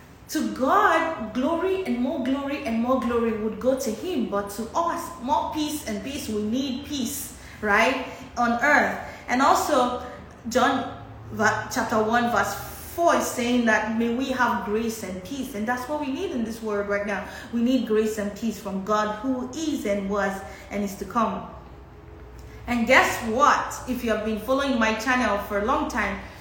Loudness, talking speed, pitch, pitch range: -24 LUFS, 185 wpm, 240 Hz, 215-270 Hz